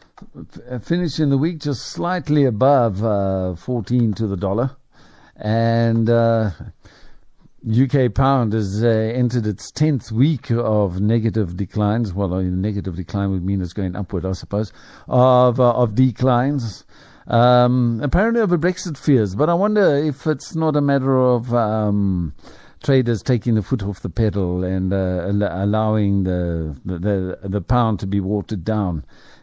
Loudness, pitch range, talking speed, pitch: -19 LUFS, 100-130 Hz, 150 wpm, 115 Hz